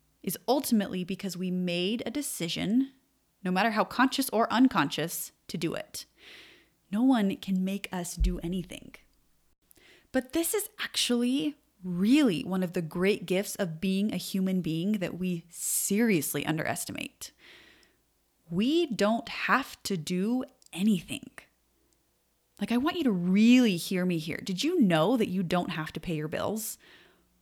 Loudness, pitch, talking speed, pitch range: -29 LUFS, 195 Hz, 150 wpm, 180-240 Hz